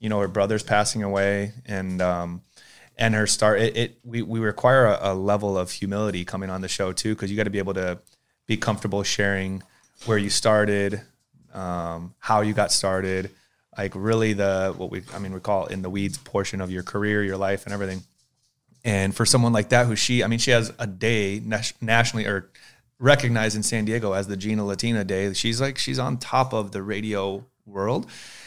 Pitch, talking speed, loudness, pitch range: 105 Hz, 205 wpm, -24 LUFS, 95-115 Hz